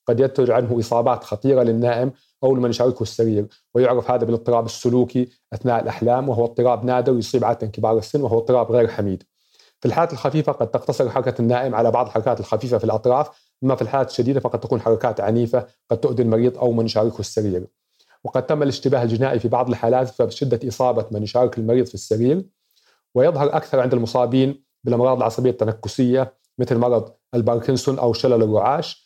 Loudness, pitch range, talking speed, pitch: -20 LUFS, 115-130 Hz, 170 wpm, 125 Hz